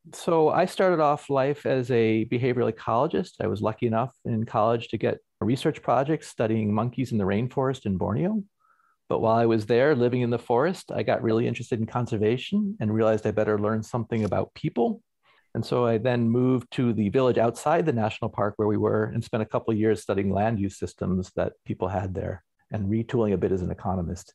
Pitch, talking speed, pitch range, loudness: 115 Hz, 210 wpm, 105-125 Hz, -25 LUFS